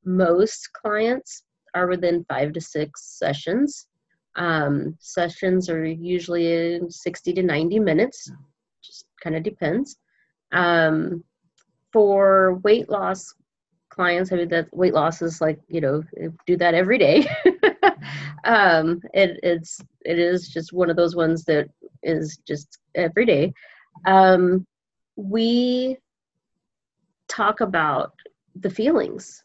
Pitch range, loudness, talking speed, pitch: 165-195 Hz, -21 LUFS, 120 wpm, 175 Hz